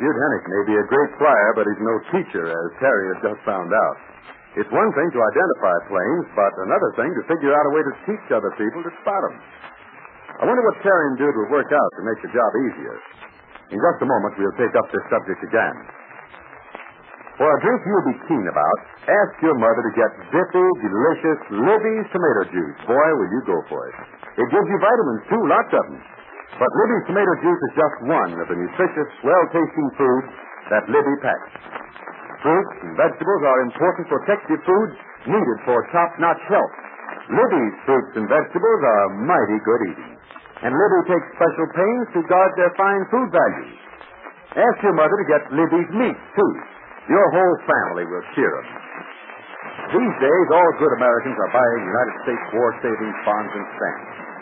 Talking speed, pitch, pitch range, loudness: 180 wpm, 175 Hz, 150-205 Hz, -19 LUFS